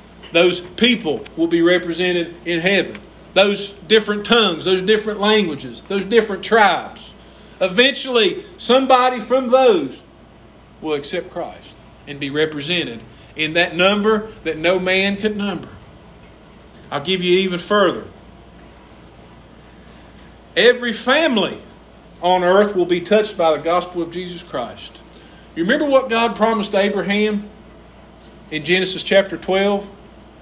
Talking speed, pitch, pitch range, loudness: 120 wpm, 190 Hz, 175-215 Hz, -17 LUFS